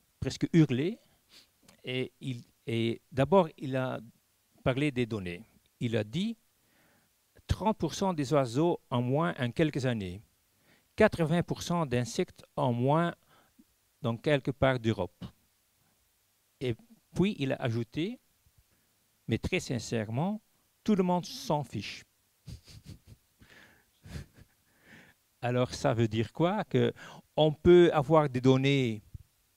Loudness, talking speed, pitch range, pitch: -30 LUFS, 110 wpm, 115-165 Hz, 135 Hz